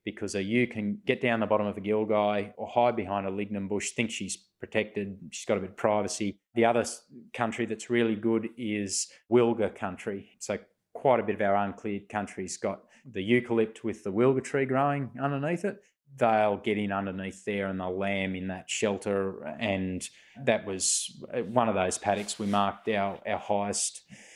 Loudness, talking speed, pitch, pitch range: -29 LUFS, 185 wpm, 105 Hz, 100-115 Hz